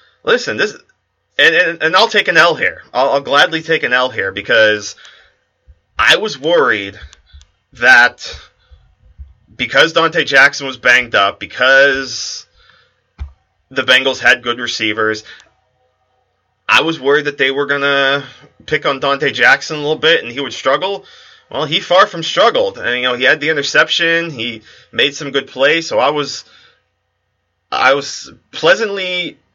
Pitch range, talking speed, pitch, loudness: 105-165 Hz, 150 wpm, 135 Hz, -13 LUFS